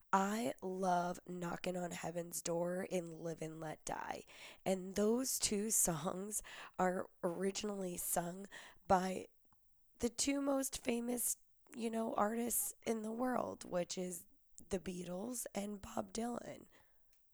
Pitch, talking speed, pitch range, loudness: 195 Hz, 125 wpm, 180-230 Hz, -40 LUFS